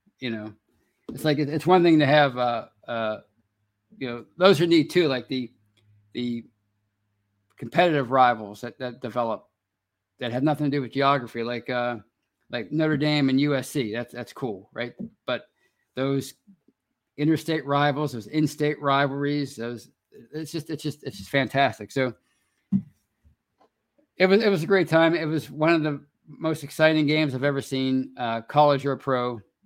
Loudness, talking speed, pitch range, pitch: -24 LUFS, 165 wpm, 120-155 Hz, 135 Hz